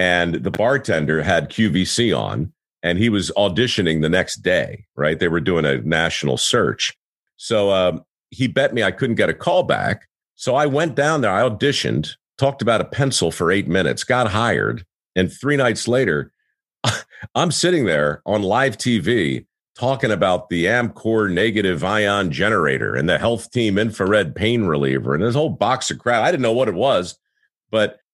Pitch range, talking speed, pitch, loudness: 85-120 Hz, 180 wpm, 100 Hz, -19 LUFS